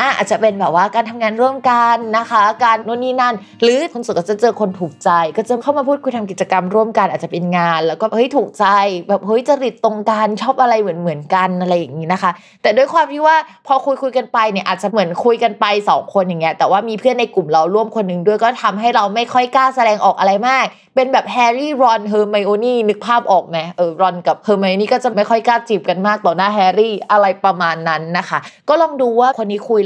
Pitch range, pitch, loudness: 190-240 Hz, 215 Hz, -15 LUFS